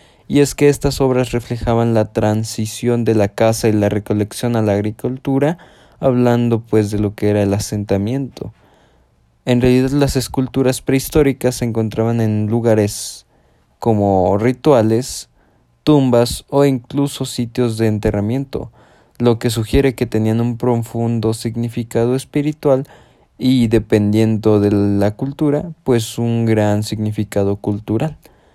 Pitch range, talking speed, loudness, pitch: 110-130 Hz, 130 wpm, -16 LUFS, 115 Hz